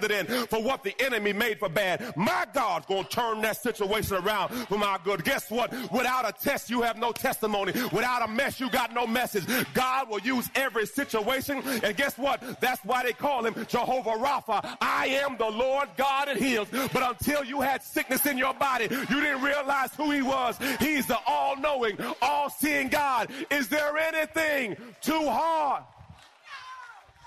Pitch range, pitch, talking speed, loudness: 230-280 Hz, 255 Hz, 175 wpm, -27 LUFS